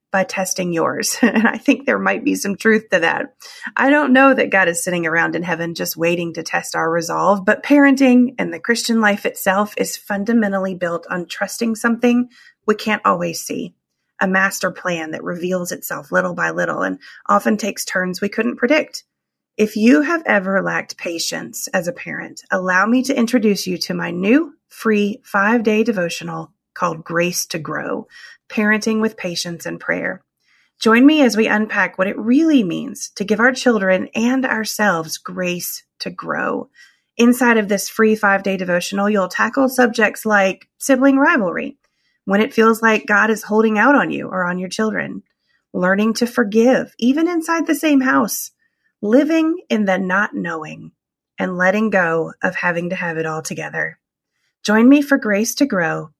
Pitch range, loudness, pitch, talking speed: 185-245 Hz, -17 LUFS, 210 Hz, 175 wpm